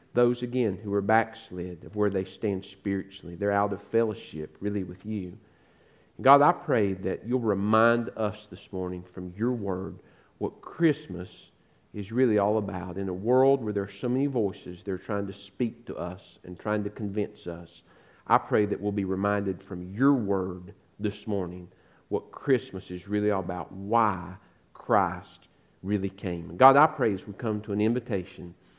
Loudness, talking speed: -28 LUFS, 180 wpm